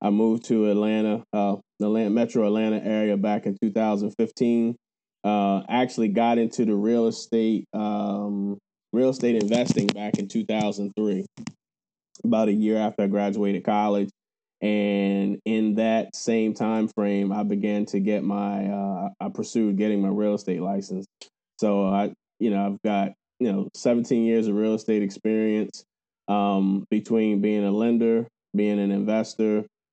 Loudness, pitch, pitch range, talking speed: -24 LUFS, 105 Hz, 100-110 Hz, 150 wpm